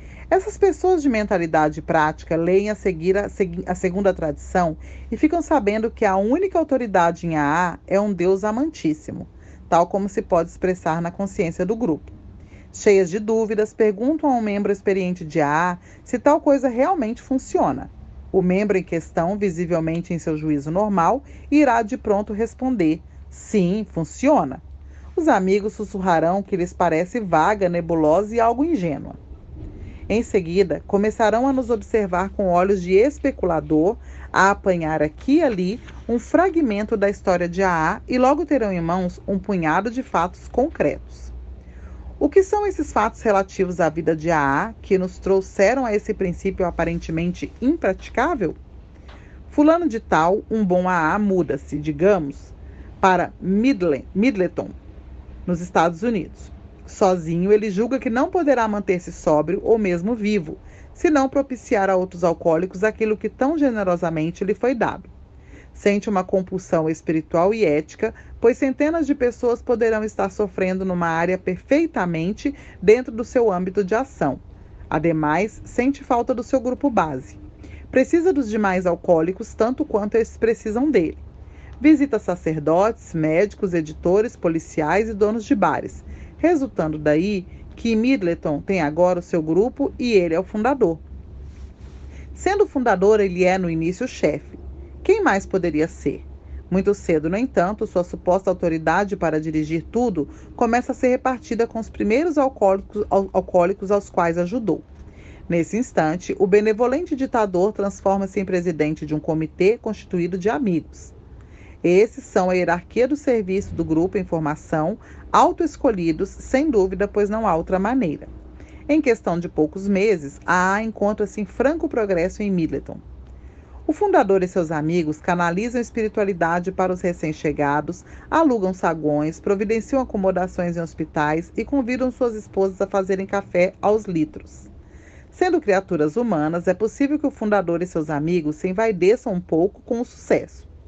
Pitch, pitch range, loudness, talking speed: 195 Hz, 170-230 Hz, -21 LUFS, 145 wpm